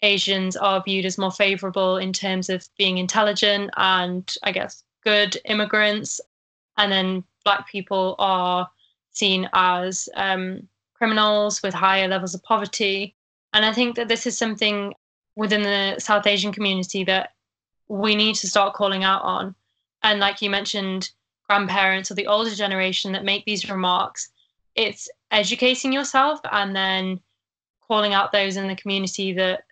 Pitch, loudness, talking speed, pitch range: 200 Hz, -21 LUFS, 150 wpm, 190-210 Hz